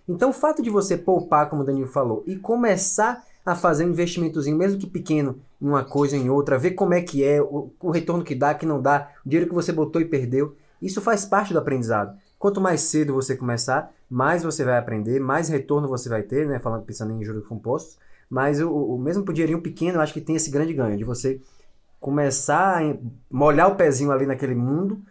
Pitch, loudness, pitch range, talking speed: 145 Hz, -23 LUFS, 135-175 Hz, 220 wpm